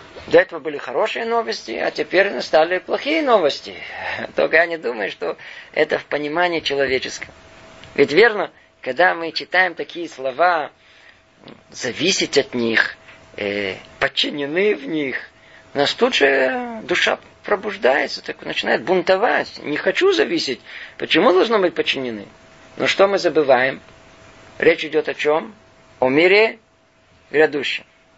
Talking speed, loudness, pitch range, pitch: 125 wpm, -19 LUFS, 130-185 Hz, 160 Hz